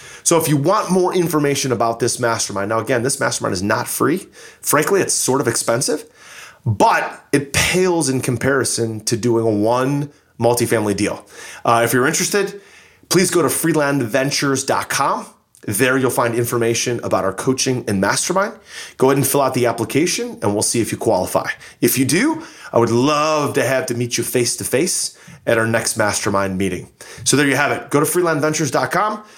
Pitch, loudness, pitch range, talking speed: 130 Hz, -17 LUFS, 115-150 Hz, 180 wpm